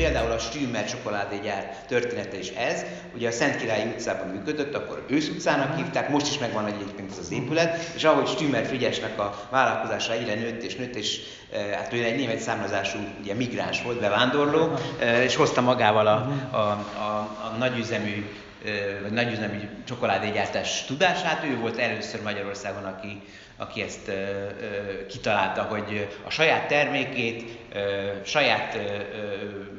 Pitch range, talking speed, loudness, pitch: 100-125 Hz, 150 wpm, -26 LUFS, 105 Hz